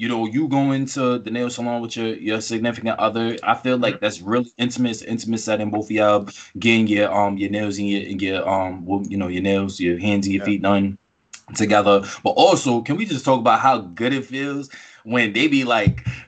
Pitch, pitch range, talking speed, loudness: 110 Hz, 100-120 Hz, 220 wpm, -20 LUFS